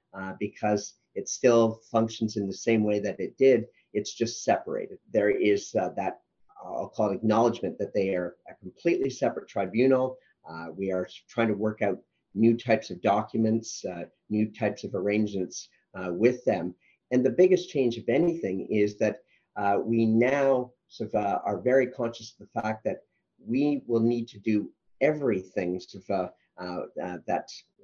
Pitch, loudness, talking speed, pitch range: 115 Hz, -27 LUFS, 175 wpm, 105-125 Hz